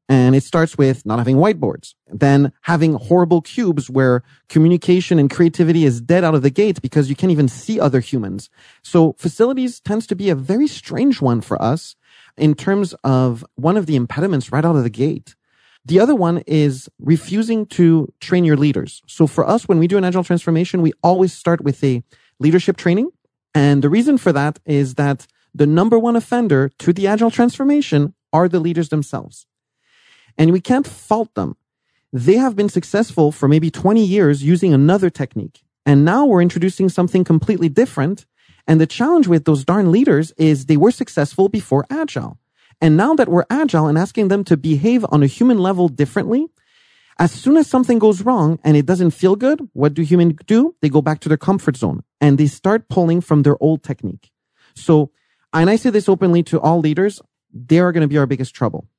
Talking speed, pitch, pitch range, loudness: 195 wpm, 165 Hz, 145-195 Hz, -16 LUFS